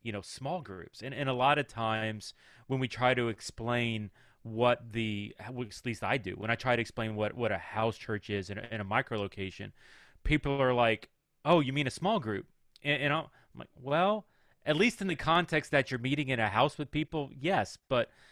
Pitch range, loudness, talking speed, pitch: 110-145 Hz, -32 LUFS, 220 wpm, 125 Hz